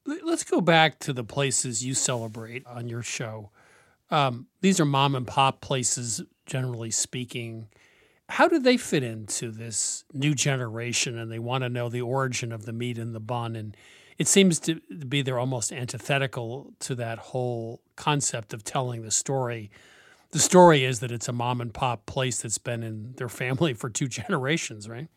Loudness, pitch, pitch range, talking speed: -26 LUFS, 125 Hz, 115-140 Hz, 180 wpm